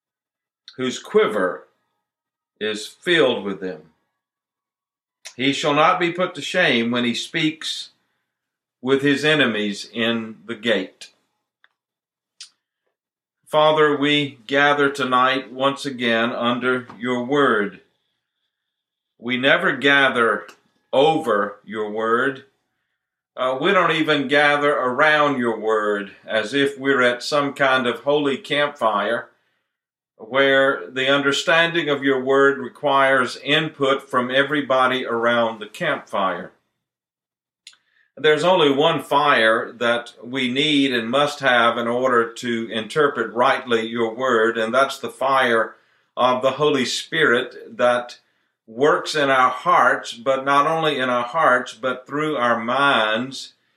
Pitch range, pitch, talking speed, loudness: 120-145 Hz, 130 Hz, 120 wpm, -19 LUFS